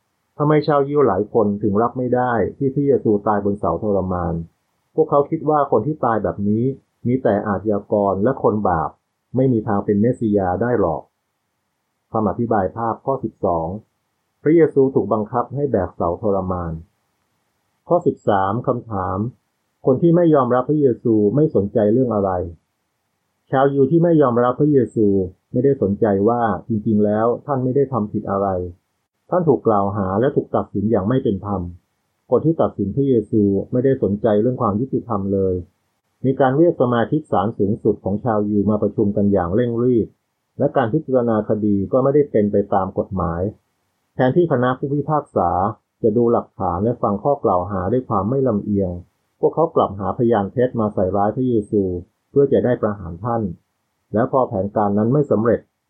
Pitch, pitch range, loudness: 110 Hz, 100-130 Hz, -19 LUFS